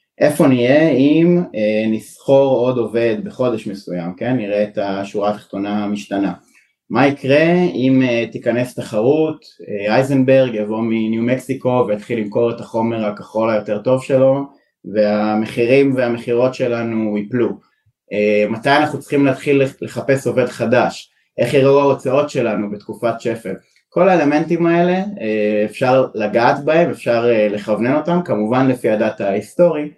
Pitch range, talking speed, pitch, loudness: 105-135 Hz, 135 wpm, 120 Hz, -16 LUFS